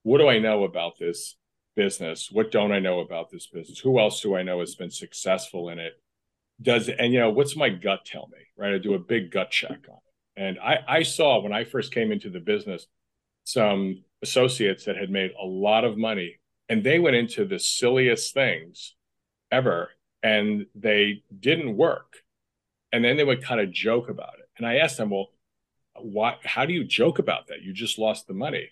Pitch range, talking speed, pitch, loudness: 95-120 Hz, 210 wpm, 105 Hz, -24 LUFS